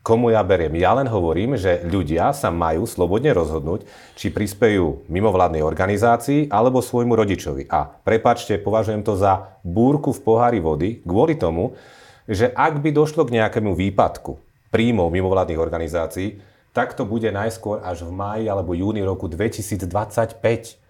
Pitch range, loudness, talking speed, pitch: 95-115 Hz, -20 LUFS, 145 wpm, 105 Hz